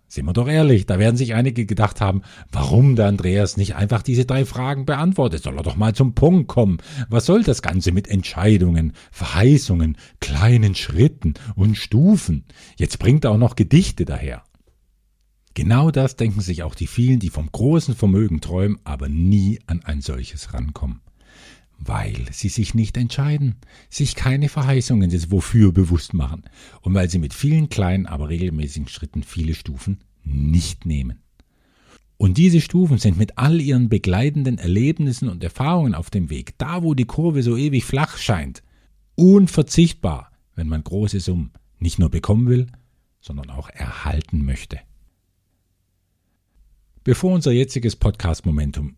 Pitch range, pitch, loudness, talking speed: 85-125 Hz, 100 Hz, -19 LUFS, 155 wpm